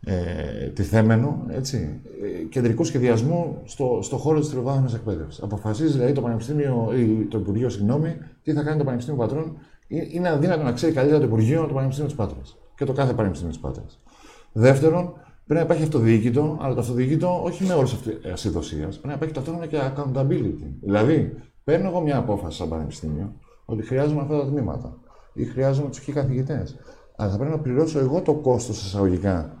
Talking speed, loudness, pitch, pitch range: 175 wpm, -23 LUFS, 130 Hz, 110-150 Hz